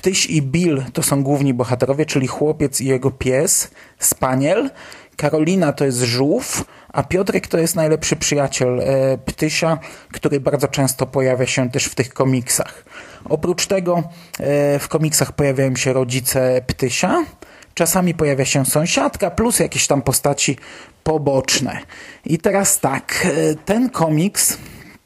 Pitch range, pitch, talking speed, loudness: 135-165 Hz, 145 Hz, 140 wpm, -17 LUFS